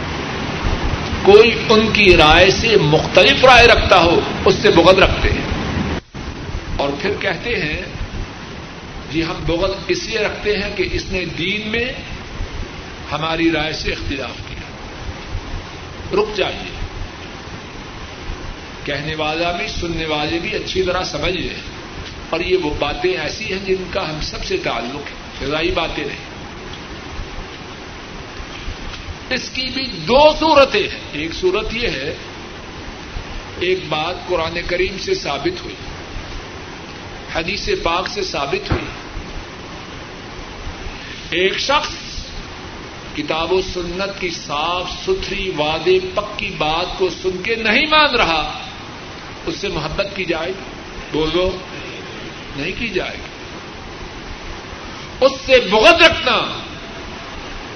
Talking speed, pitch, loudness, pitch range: 120 wpm, 180 Hz, -16 LUFS, 150-215 Hz